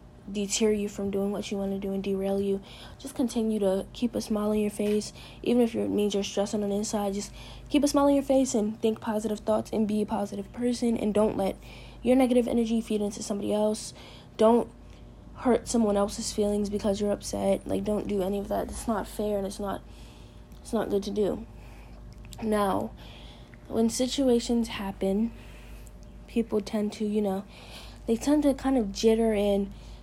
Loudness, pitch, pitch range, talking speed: -28 LUFS, 210 Hz, 200-230 Hz, 195 wpm